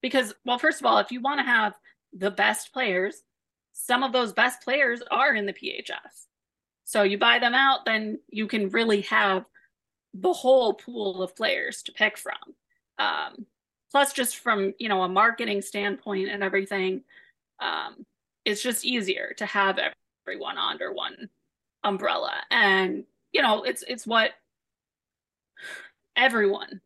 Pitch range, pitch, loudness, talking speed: 200-260 Hz, 225 Hz, -25 LUFS, 150 wpm